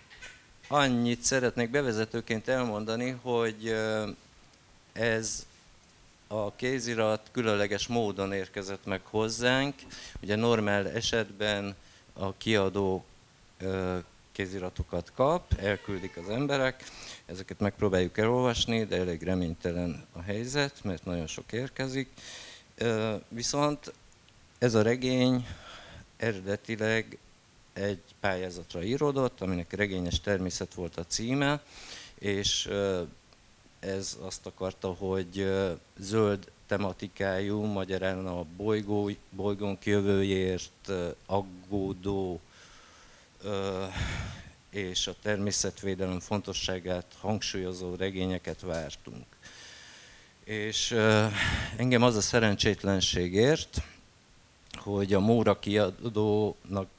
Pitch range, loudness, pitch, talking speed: 95-115 Hz, -30 LUFS, 100 Hz, 80 wpm